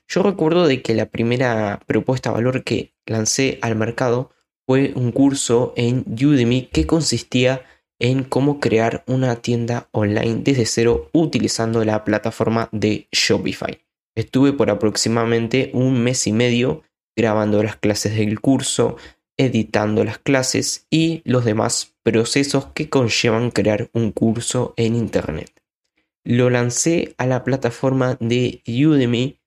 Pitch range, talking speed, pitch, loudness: 115-130 Hz, 135 wpm, 120 Hz, -19 LUFS